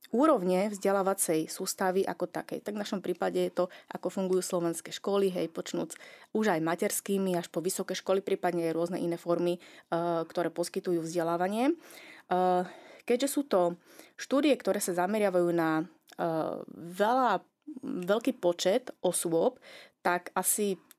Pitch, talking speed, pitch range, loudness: 185 Hz, 130 wpm, 175-205 Hz, -30 LUFS